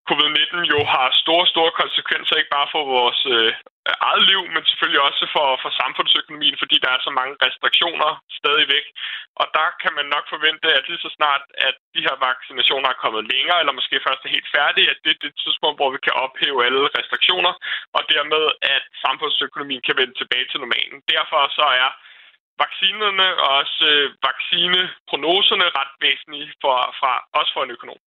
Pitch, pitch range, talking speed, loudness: 155 Hz, 145-175 Hz, 180 wpm, -18 LUFS